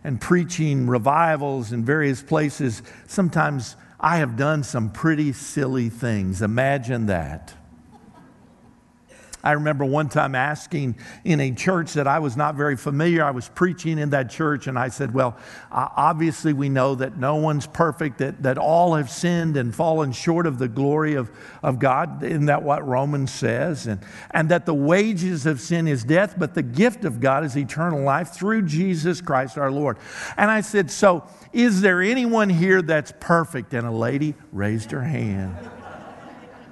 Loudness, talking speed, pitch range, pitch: -22 LUFS, 170 wpm, 130-165 Hz, 145 Hz